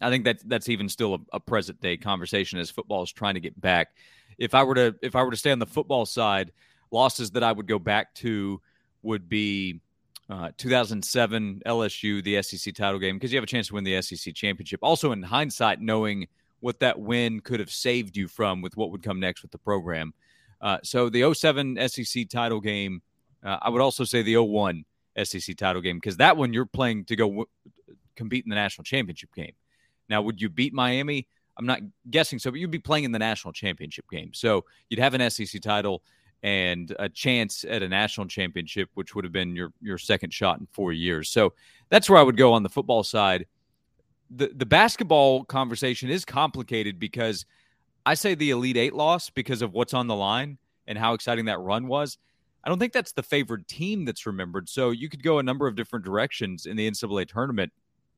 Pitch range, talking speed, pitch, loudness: 100-130 Hz, 215 wpm, 115 Hz, -25 LUFS